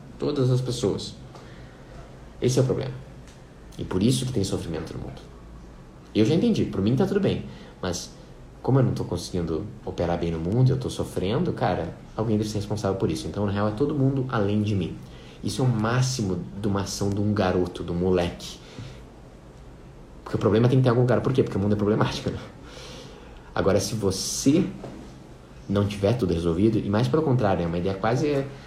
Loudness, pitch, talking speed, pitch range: -25 LUFS, 100 Hz, 205 wpm, 90-115 Hz